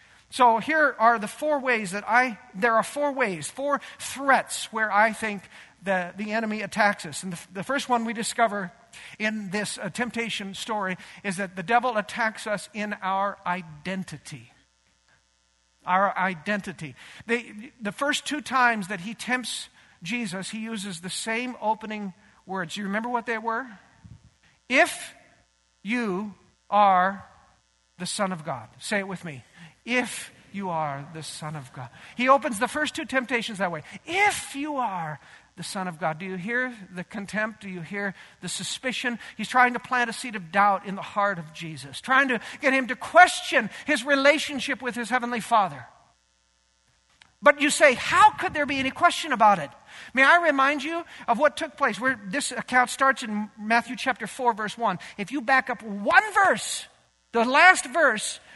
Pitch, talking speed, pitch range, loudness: 215 Hz, 175 wpm, 185-255 Hz, -24 LUFS